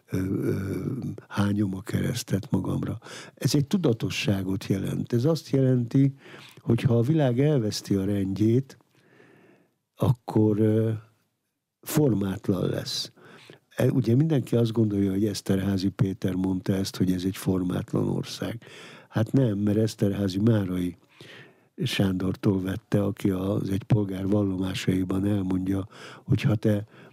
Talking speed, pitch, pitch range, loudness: 110 wpm, 105 Hz, 95-125 Hz, -26 LUFS